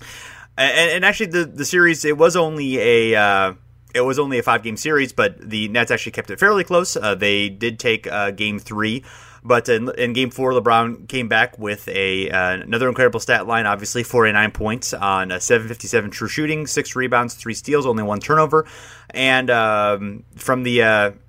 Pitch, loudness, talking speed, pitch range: 120 Hz, -18 LUFS, 195 wpm, 105-130 Hz